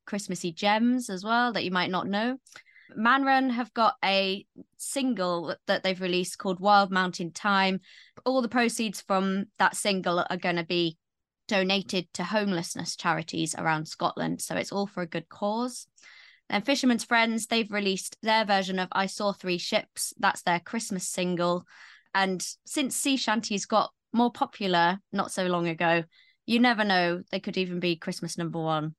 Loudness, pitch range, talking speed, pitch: -27 LUFS, 180-225 Hz, 170 wpm, 195 Hz